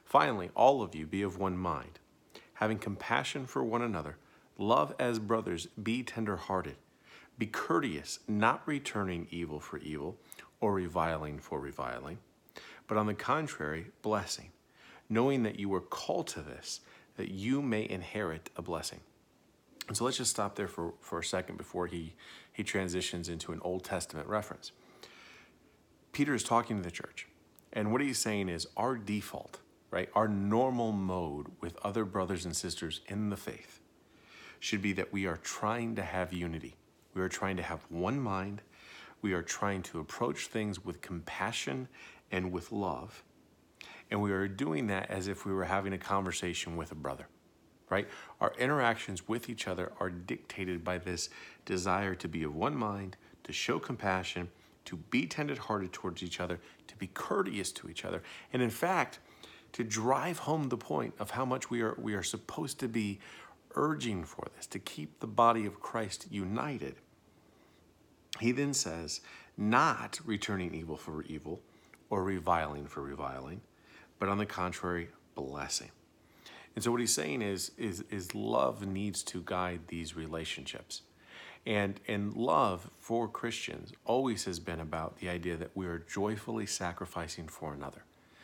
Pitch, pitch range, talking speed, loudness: 95 Hz, 85-110 Hz, 165 wpm, -35 LUFS